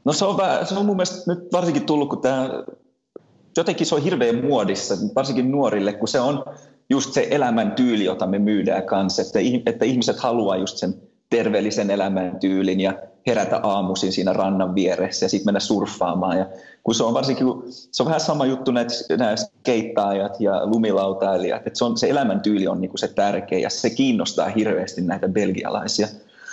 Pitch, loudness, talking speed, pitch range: 110 Hz, -21 LUFS, 175 wpm, 95-135 Hz